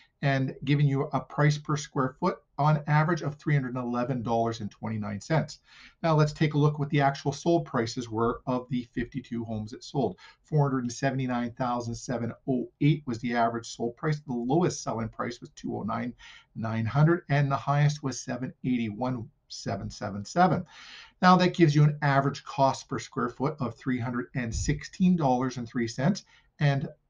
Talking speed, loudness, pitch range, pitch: 130 wpm, -28 LUFS, 120-150 Hz, 135 Hz